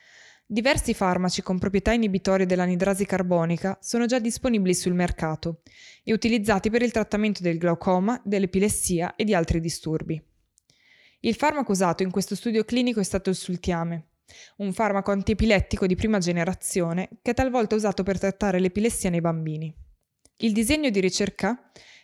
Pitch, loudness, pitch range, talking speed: 195 Hz, -24 LUFS, 180-220 Hz, 145 wpm